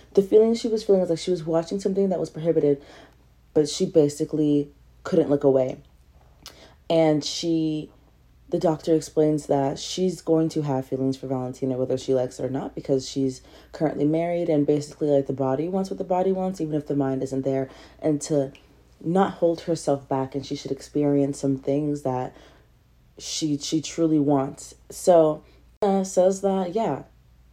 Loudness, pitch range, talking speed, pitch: -24 LUFS, 135-165 Hz, 175 wpm, 150 Hz